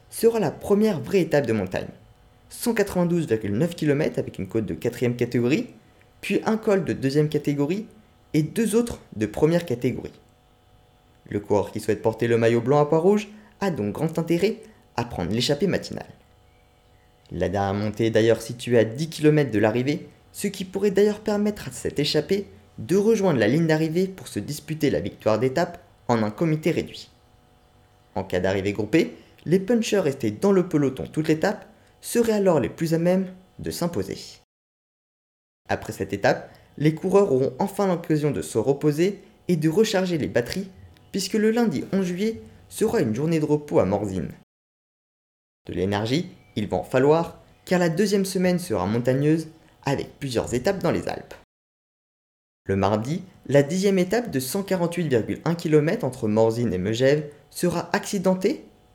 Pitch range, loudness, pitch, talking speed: 120-185 Hz, -24 LUFS, 150 Hz, 165 wpm